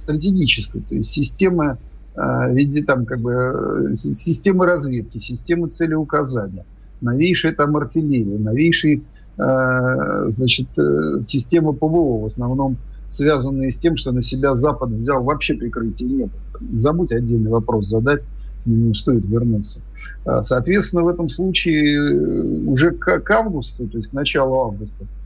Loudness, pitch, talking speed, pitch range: -19 LUFS, 130 Hz, 125 wpm, 115-155 Hz